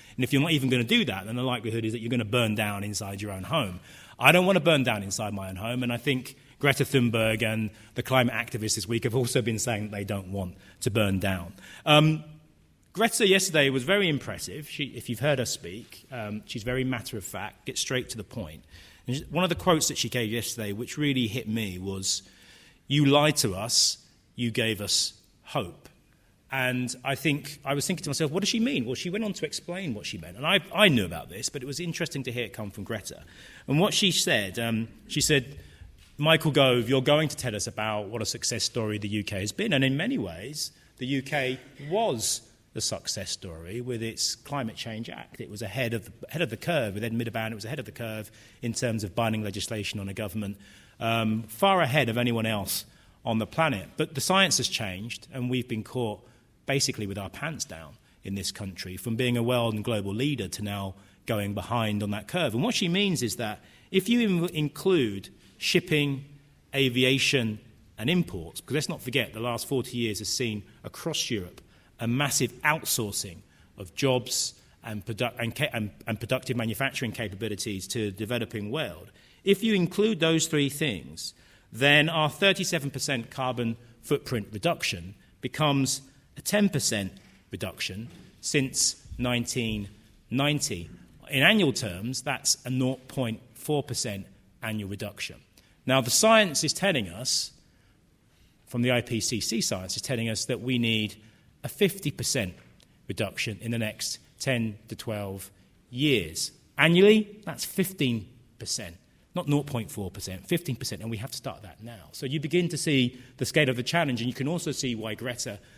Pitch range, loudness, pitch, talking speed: 105-140 Hz, -27 LUFS, 120 Hz, 190 wpm